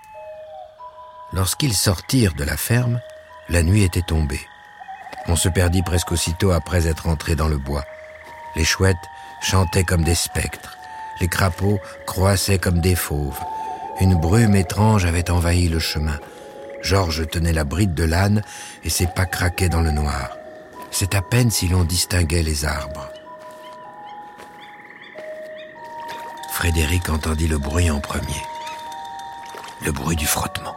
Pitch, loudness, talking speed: 95 Hz, -20 LUFS, 135 wpm